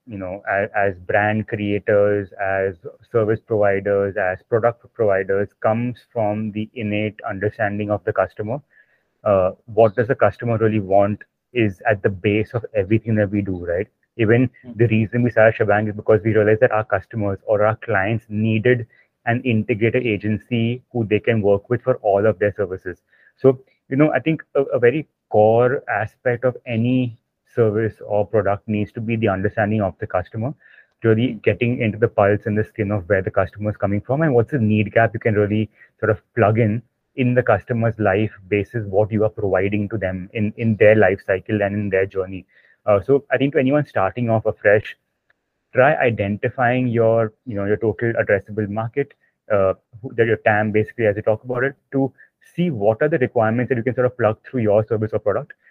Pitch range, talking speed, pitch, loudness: 105-120 Hz, 195 wpm, 110 Hz, -20 LUFS